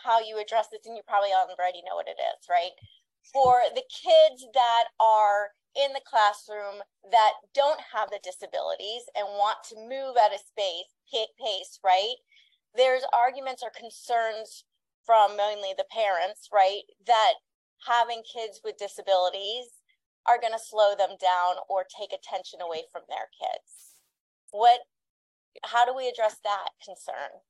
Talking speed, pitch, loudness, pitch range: 155 wpm, 220 Hz, -26 LUFS, 200-245 Hz